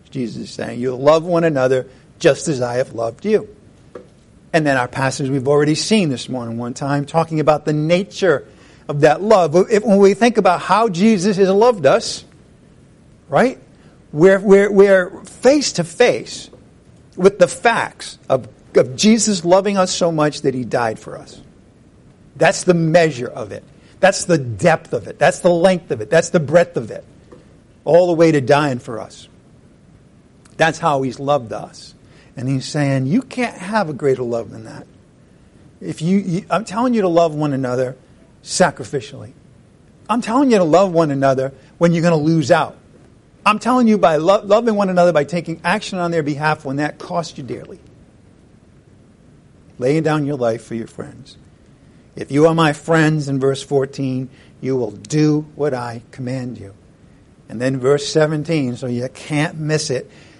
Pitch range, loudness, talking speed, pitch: 135-180 Hz, -16 LUFS, 175 wpm, 155 Hz